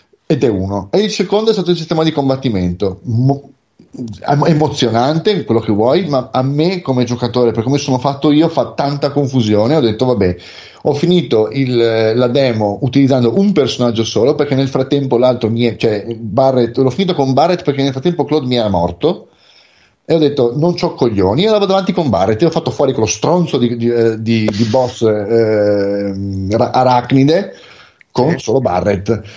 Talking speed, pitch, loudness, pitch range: 180 wpm, 130 Hz, -14 LUFS, 115-150 Hz